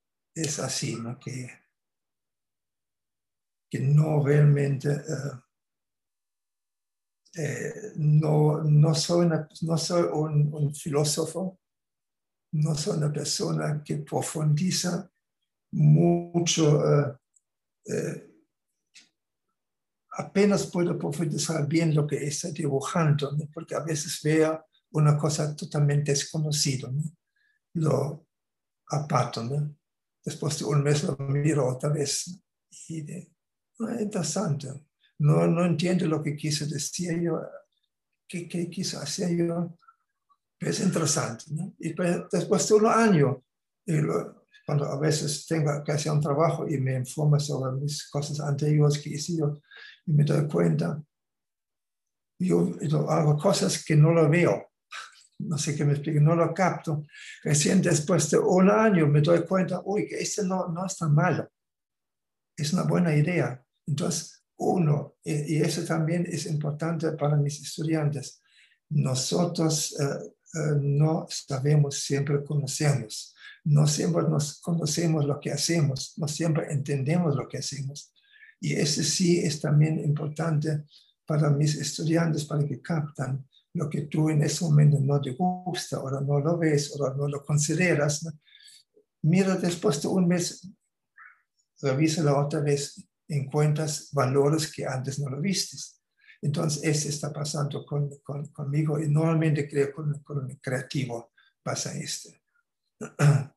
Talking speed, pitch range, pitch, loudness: 135 wpm, 145-170 Hz, 155 Hz, -26 LUFS